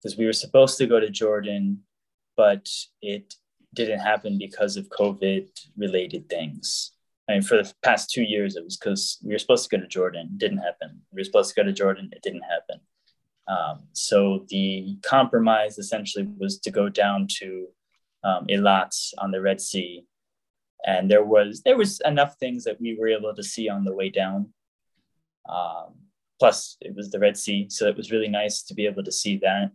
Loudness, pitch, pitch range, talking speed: -24 LUFS, 105 Hz, 100-115 Hz, 200 wpm